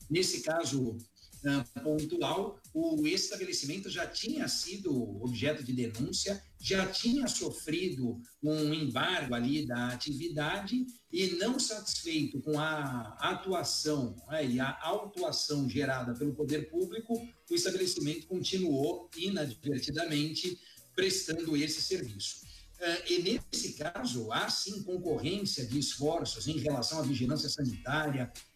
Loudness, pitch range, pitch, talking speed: -33 LUFS, 130-185 Hz, 150 Hz, 115 wpm